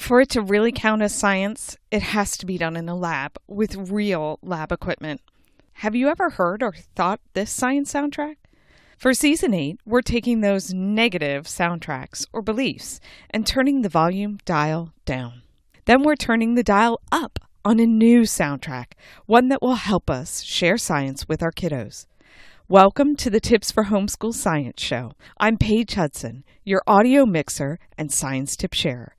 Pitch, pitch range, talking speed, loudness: 200 Hz, 160-235 Hz, 170 wpm, -21 LUFS